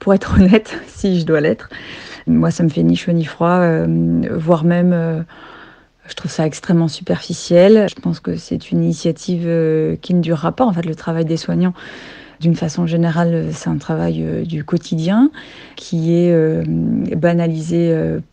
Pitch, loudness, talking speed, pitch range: 165 Hz, -16 LUFS, 180 wpm, 155-175 Hz